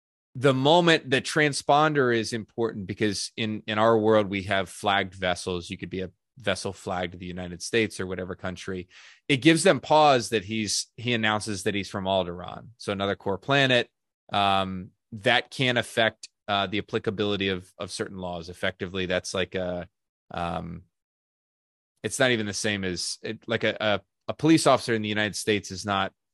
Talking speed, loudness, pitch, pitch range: 180 wpm, -25 LUFS, 105 Hz, 95-115 Hz